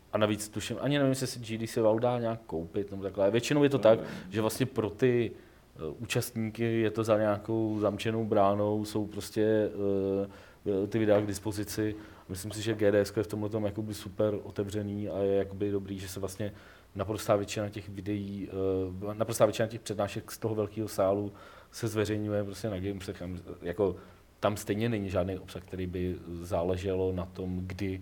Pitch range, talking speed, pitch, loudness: 100-110 Hz, 180 wpm, 105 Hz, -31 LUFS